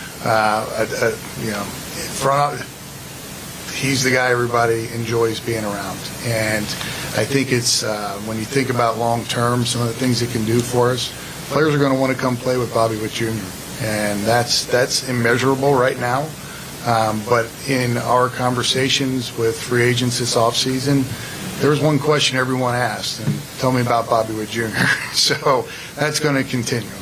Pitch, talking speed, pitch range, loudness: 120 Hz, 175 wpm, 115-135 Hz, -19 LUFS